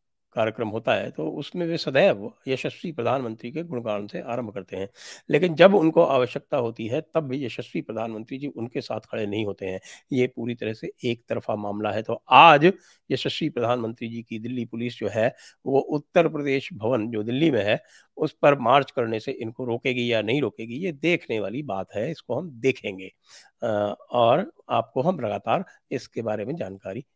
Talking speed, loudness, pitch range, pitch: 210 wpm, -24 LUFS, 110-140 Hz, 120 Hz